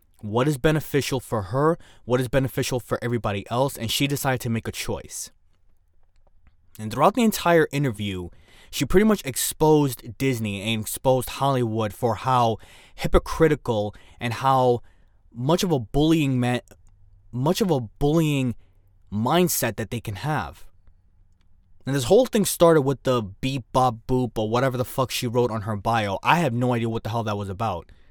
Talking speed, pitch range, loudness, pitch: 170 wpm, 100-135 Hz, -23 LUFS, 120 Hz